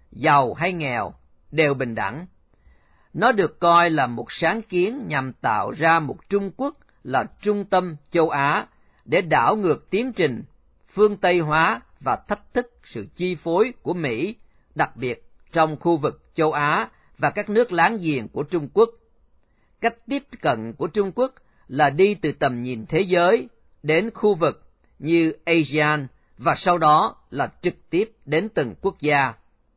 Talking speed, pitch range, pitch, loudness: 165 wpm, 140-200 Hz, 165 Hz, -22 LUFS